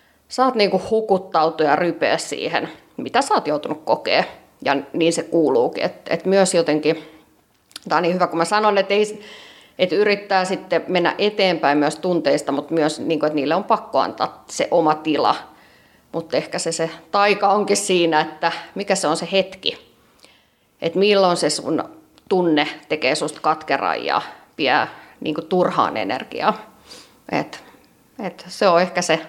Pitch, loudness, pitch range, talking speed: 175 Hz, -20 LUFS, 160-195 Hz, 155 wpm